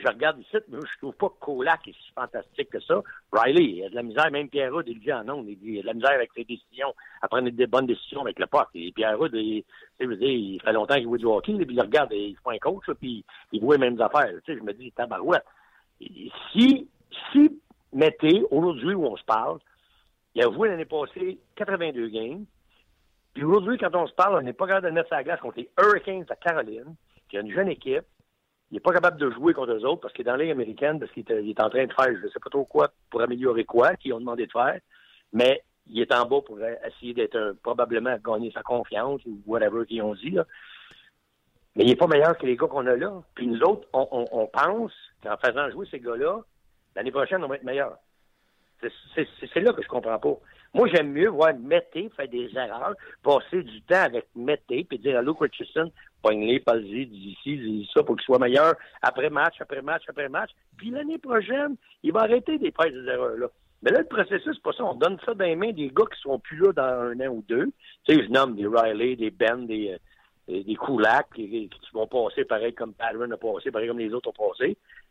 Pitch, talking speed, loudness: 195 Hz, 240 wpm, -25 LUFS